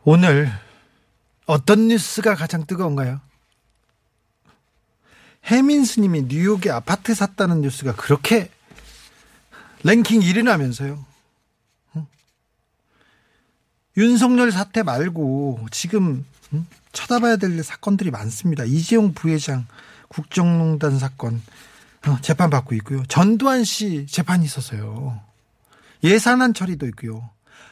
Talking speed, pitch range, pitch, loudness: 220 characters per minute, 135-205 Hz, 160 Hz, -19 LUFS